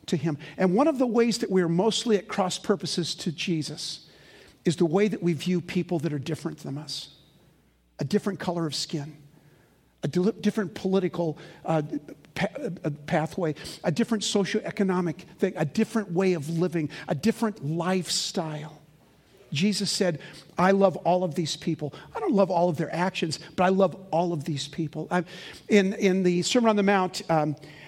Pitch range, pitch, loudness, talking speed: 155-195 Hz, 175 Hz, -26 LUFS, 175 wpm